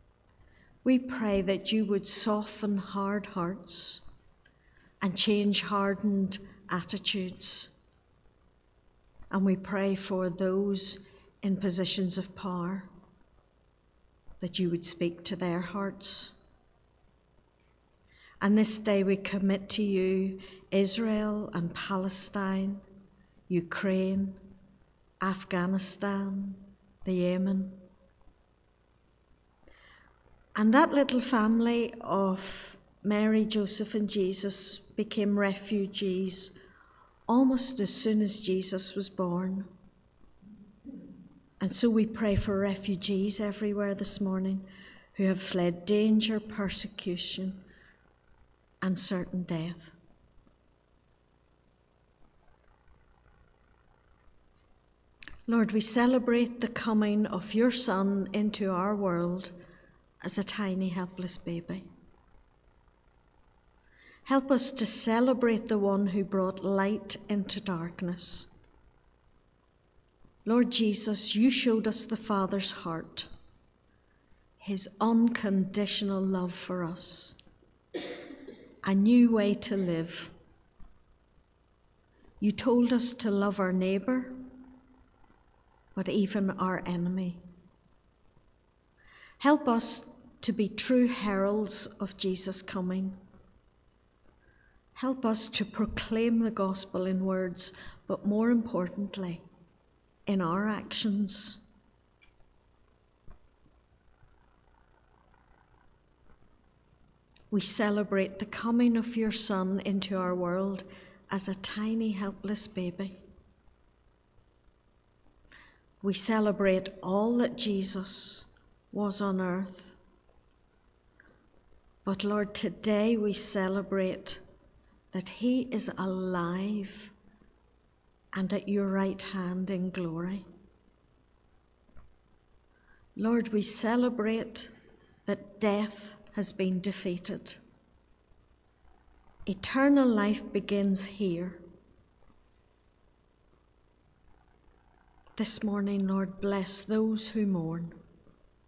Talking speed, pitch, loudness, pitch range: 85 wpm, 190 Hz, -29 LUFS, 165-210 Hz